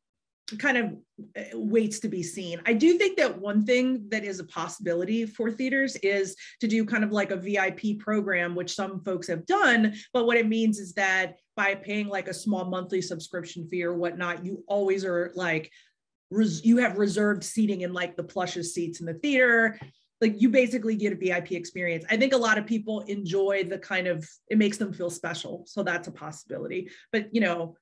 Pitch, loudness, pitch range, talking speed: 195 Hz, -27 LUFS, 180-220 Hz, 205 wpm